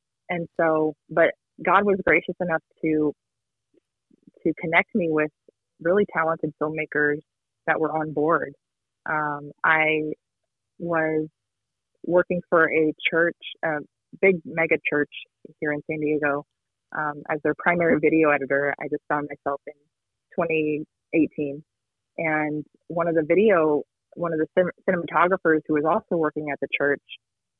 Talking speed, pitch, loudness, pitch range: 135 wpm, 155 Hz, -24 LUFS, 145-165 Hz